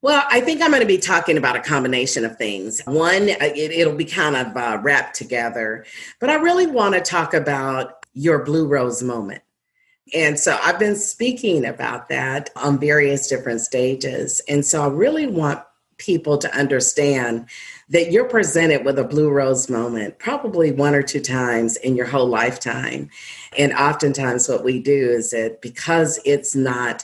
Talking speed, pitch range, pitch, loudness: 175 wpm, 125-165 Hz, 145 Hz, -19 LUFS